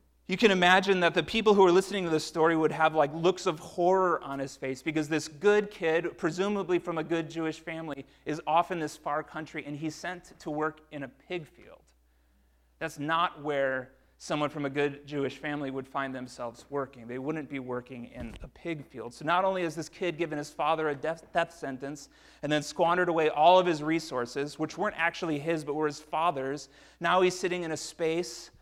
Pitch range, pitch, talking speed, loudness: 140-170 Hz, 155 Hz, 215 wpm, -29 LUFS